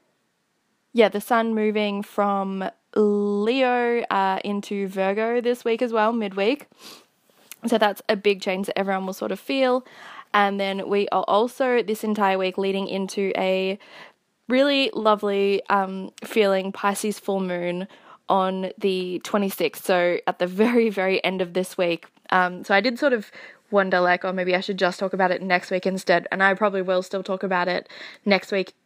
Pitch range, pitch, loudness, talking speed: 190-220 Hz, 200 Hz, -23 LUFS, 175 wpm